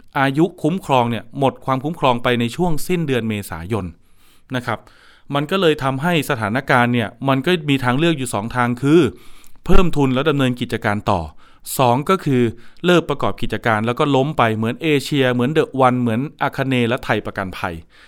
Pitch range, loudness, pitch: 115-145 Hz, -19 LUFS, 125 Hz